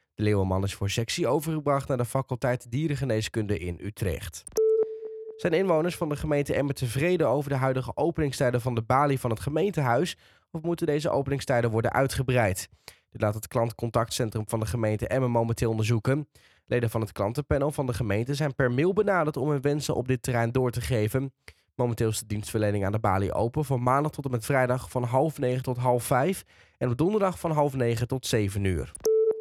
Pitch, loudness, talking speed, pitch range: 125 Hz, -27 LUFS, 195 wpm, 115-145 Hz